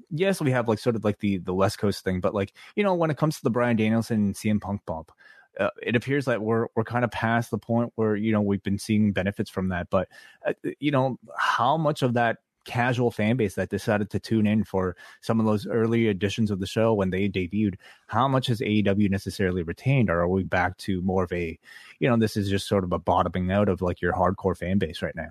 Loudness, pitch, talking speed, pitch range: -25 LUFS, 105 Hz, 255 wpm, 95-115 Hz